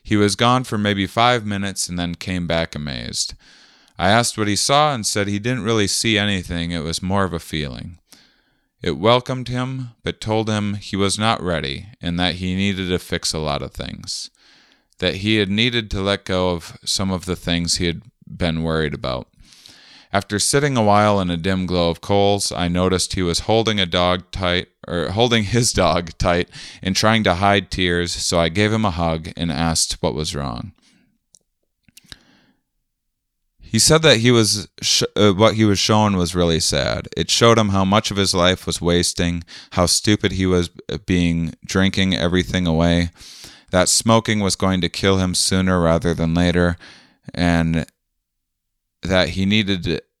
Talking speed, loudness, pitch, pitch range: 185 wpm, -19 LUFS, 95 Hz, 85-105 Hz